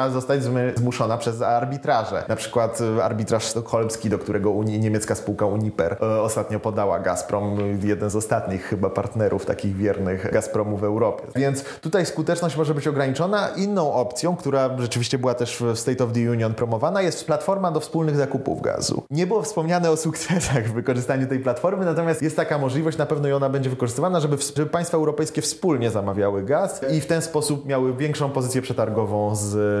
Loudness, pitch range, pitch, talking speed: -23 LUFS, 110-155 Hz, 130 Hz, 175 wpm